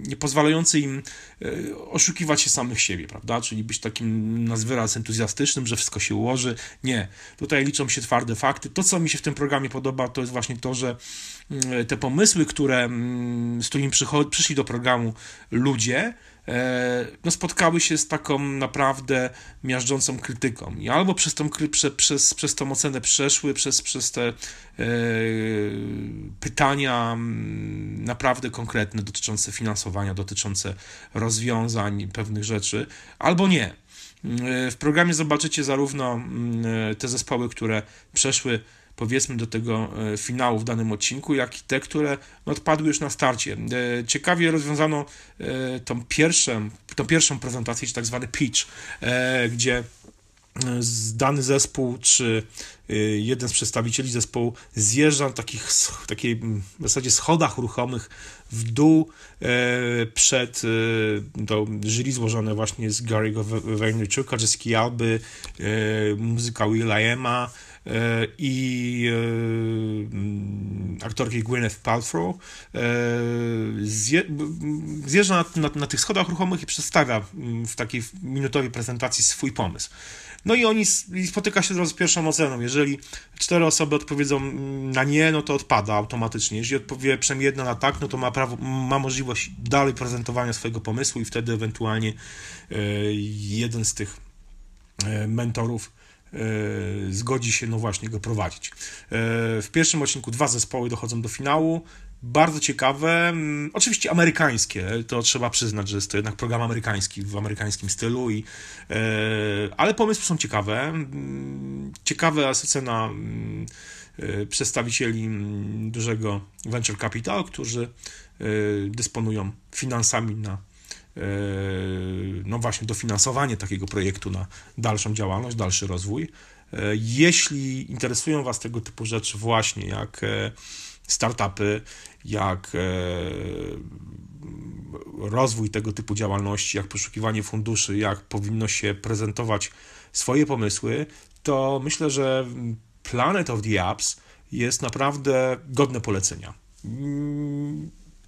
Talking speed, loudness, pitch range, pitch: 120 wpm, -24 LUFS, 105-140 Hz, 120 Hz